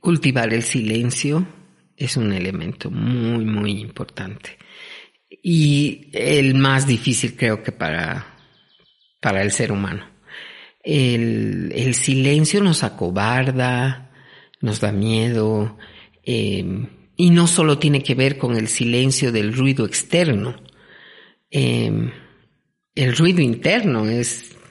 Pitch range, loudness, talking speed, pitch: 110-140 Hz, -19 LUFS, 110 wpm, 125 Hz